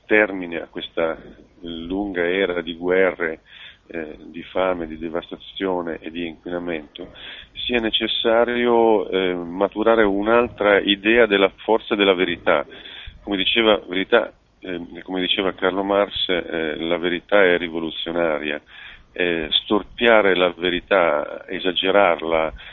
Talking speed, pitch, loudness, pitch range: 115 wpm, 95 Hz, -20 LUFS, 85-100 Hz